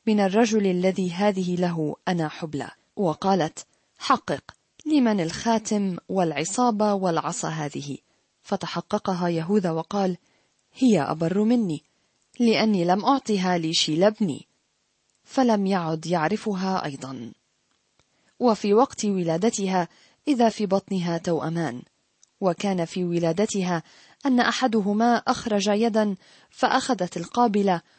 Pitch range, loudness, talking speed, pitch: 170-220 Hz, -24 LUFS, 95 wpm, 195 Hz